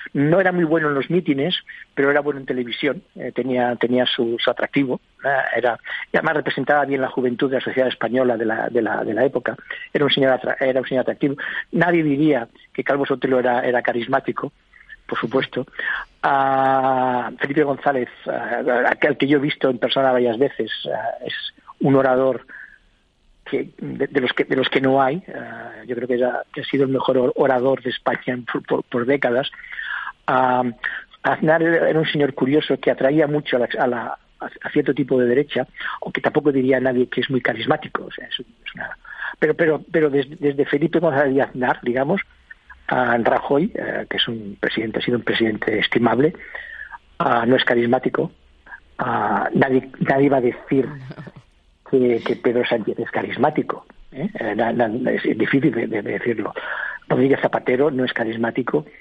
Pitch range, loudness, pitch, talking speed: 125-145 Hz, -20 LUFS, 135 Hz, 180 wpm